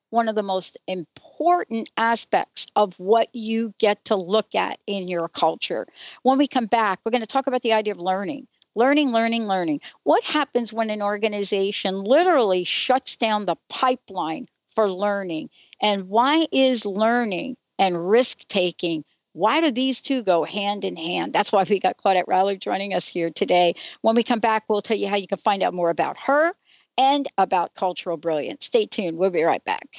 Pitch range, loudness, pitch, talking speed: 190-245 Hz, -22 LUFS, 210 Hz, 190 wpm